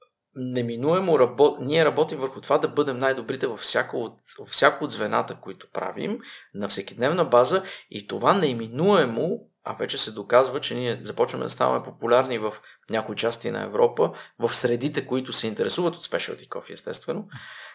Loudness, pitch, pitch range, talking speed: -24 LUFS, 145 Hz, 125-190 Hz, 160 wpm